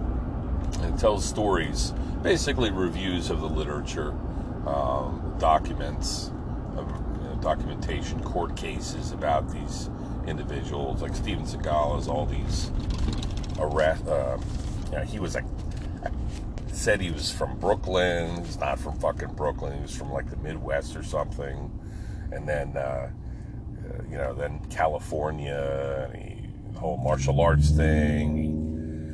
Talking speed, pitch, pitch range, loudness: 130 wpm, 80 Hz, 75-90 Hz, -29 LUFS